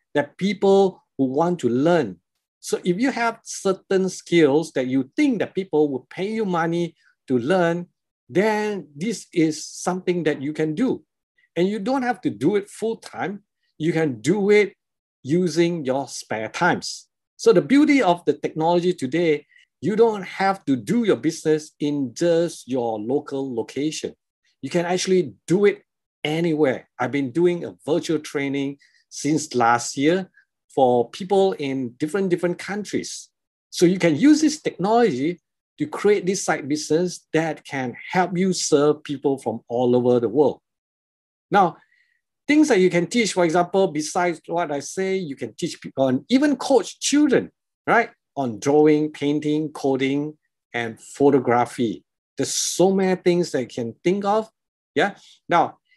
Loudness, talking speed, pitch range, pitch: -22 LUFS, 160 wpm, 145-195 Hz, 170 Hz